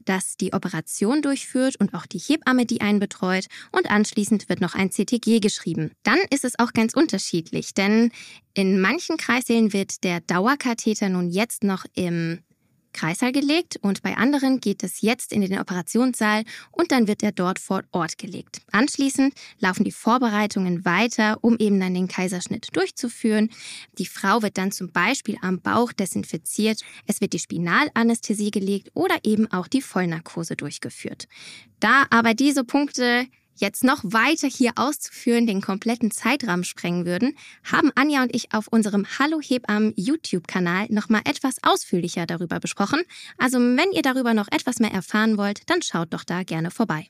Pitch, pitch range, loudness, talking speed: 215 Hz, 190-255 Hz, -22 LUFS, 165 wpm